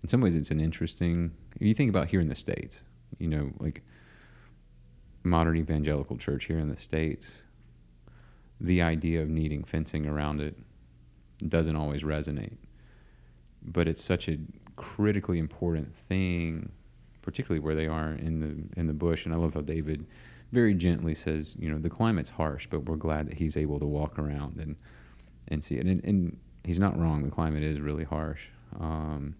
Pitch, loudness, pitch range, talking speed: 75 Hz, -30 LUFS, 70-85 Hz, 180 wpm